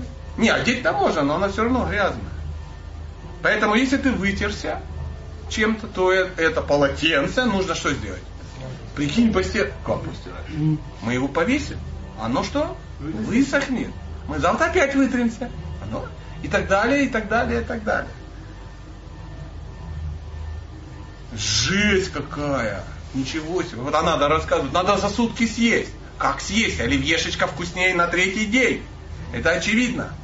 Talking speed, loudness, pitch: 125 wpm, -21 LUFS, 145 Hz